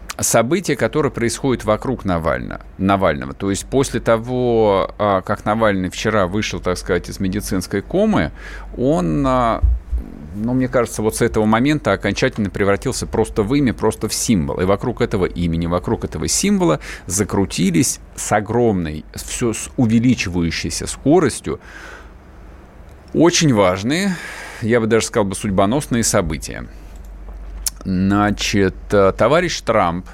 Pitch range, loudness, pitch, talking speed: 90-115 Hz, -18 LUFS, 100 Hz, 120 wpm